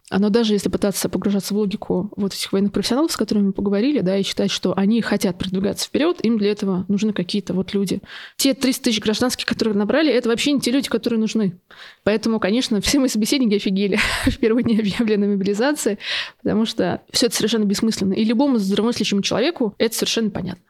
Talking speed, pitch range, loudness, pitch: 195 wpm, 200-235 Hz, -20 LUFS, 215 Hz